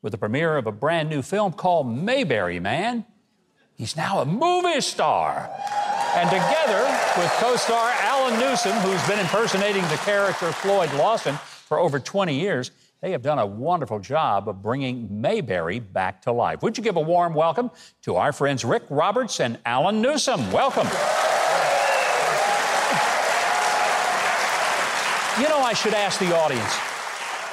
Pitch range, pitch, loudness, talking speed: 145-230 Hz, 190 Hz, -22 LUFS, 150 wpm